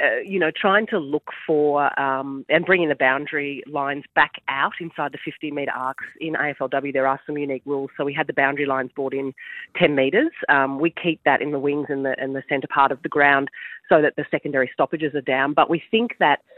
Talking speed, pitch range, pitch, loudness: 230 wpm, 135-155 Hz, 145 Hz, -21 LUFS